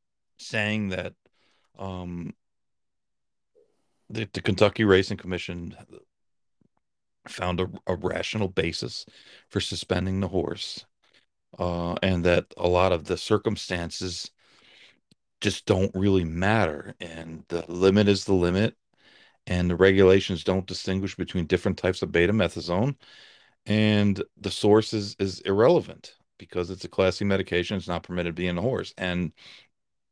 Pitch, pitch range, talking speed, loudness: 95 Hz, 90-100 Hz, 125 wpm, -25 LUFS